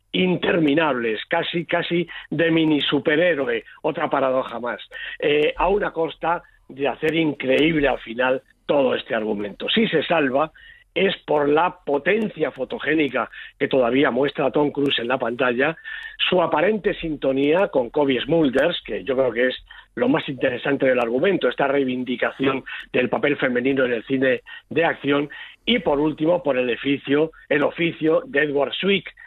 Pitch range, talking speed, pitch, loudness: 135-170 Hz, 150 wpm, 150 Hz, -21 LUFS